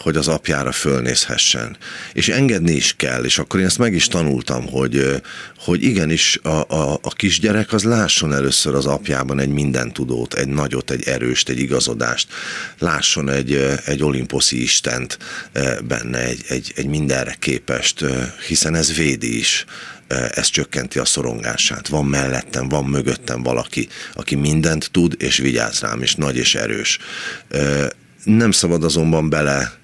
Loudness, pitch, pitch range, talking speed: -18 LUFS, 70 Hz, 65-80 Hz, 145 wpm